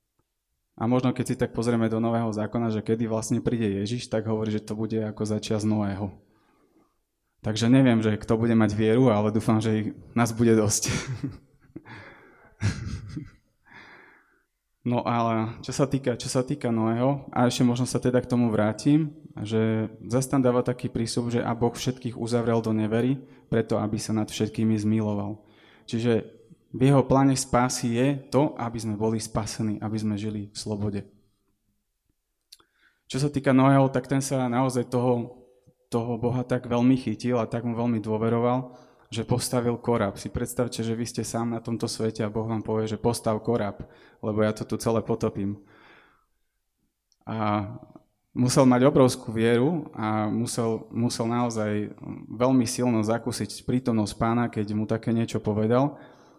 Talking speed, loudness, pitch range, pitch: 160 wpm, -25 LUFS, 110-125 Hz, 115 Hz